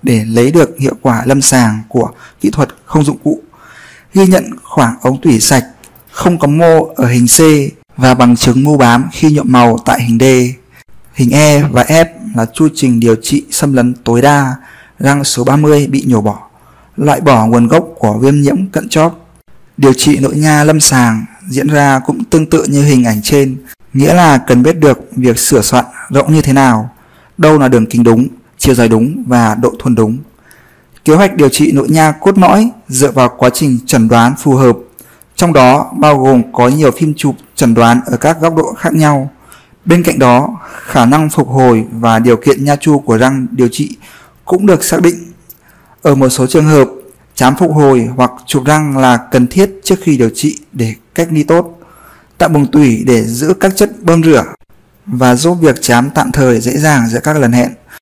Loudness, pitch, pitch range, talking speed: -9 LUFS, 135 Hz, 125-155 Hz, 205 wpm